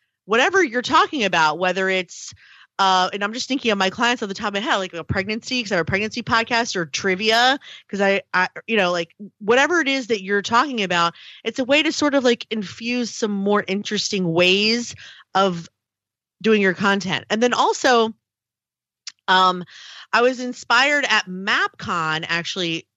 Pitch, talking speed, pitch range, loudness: 210 Hz, 185 wpm, 185-240 Hz, -19 LUFS